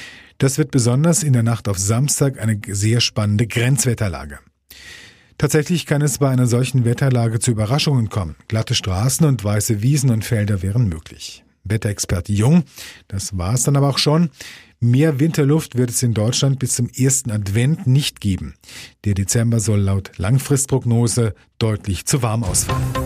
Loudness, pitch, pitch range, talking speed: -18 LUFS, 120 Hz, 105-135 Hz, 160 wpm